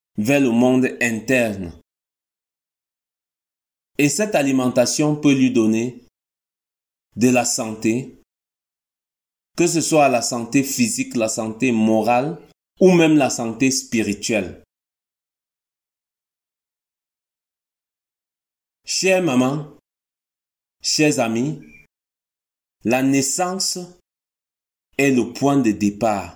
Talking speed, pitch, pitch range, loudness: 85 wpm, 120 Hz, 105-140 Hz, -18 LUFS